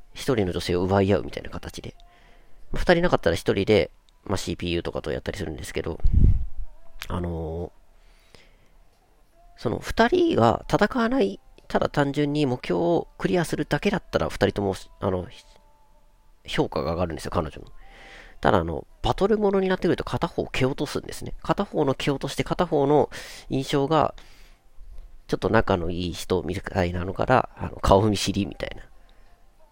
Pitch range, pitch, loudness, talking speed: 90-150 Hz, 100 Hz, -25 LUFS, 315 characters per minute